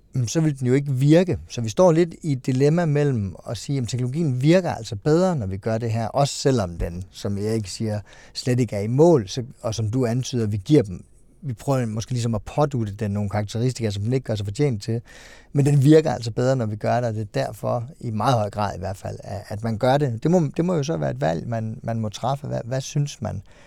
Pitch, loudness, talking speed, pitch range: 120 Hz, -23 LUFS, 260 wpm, 110-140 Hz